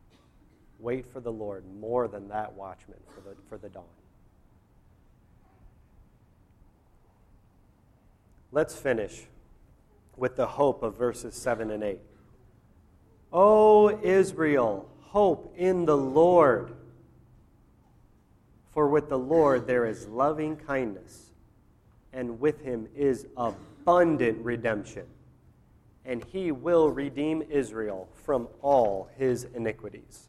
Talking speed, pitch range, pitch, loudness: 105 wpm, 105-140 Hz, 120 Hz, -26 LUFS